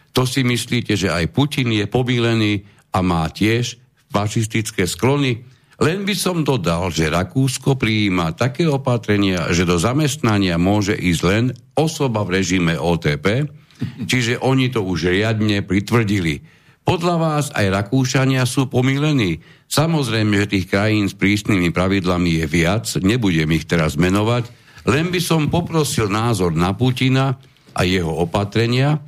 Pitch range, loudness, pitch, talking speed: 95-135 Hz, -18 LUFS, 115 Hz, 140 wpm